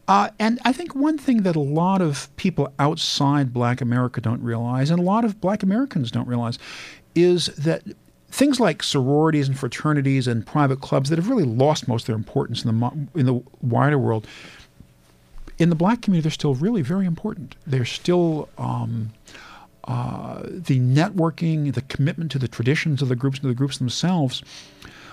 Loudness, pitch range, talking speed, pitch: -22 LUFS, 125-175 Hz, 180 wpm, 145 Hz